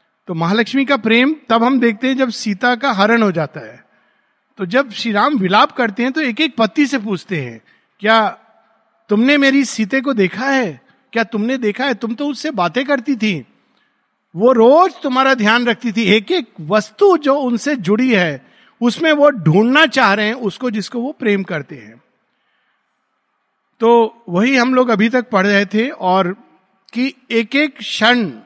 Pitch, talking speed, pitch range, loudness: 230 Hz, 175 wpm, 205-265 Hz, -15 LUFS